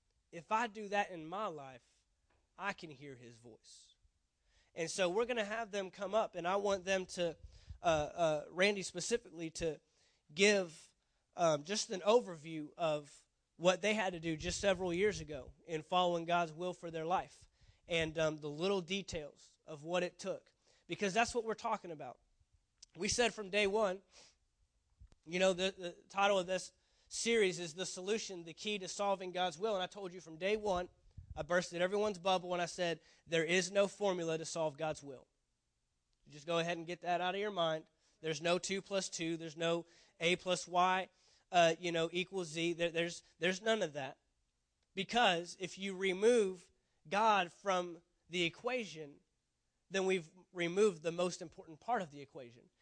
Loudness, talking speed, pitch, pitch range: -37 LUFS, 185 wpm, 180 Hz, 165-195 Hz